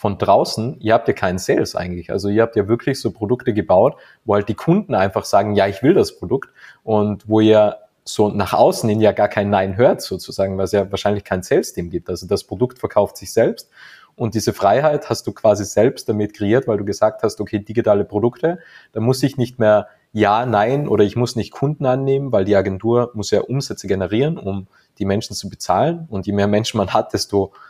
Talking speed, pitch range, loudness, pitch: 220 wpm, 100-120 Hz, -18 LUFS, 105 Hz